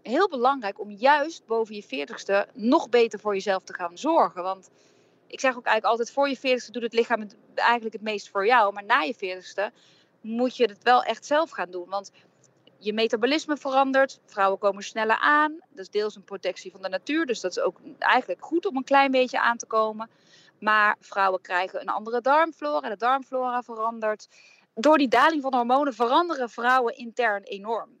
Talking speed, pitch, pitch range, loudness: 195 wpm, 230 Hz, 200-265 Hz, -24 LUFS